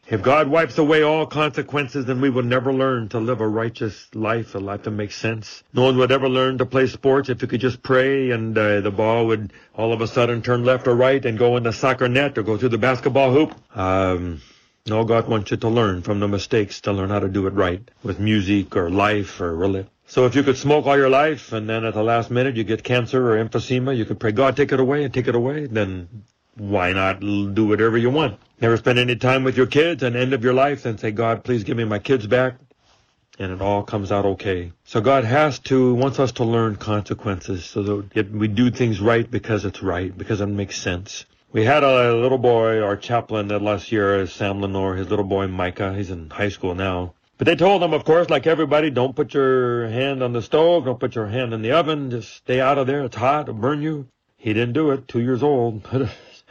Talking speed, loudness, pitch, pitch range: 240 wpm, -20 LUFS, 115 Hz, 105-130 Hz